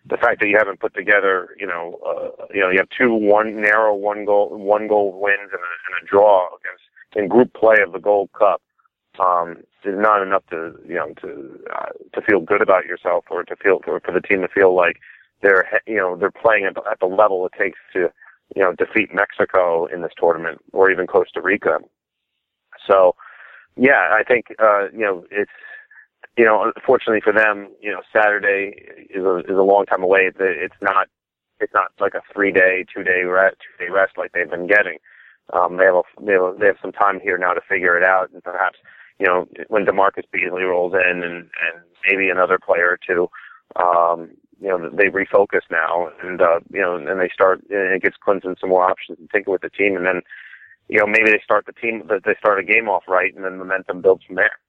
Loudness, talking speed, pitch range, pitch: -18 LUFS, 215 wpm, 95-140 Hz, 100 Hz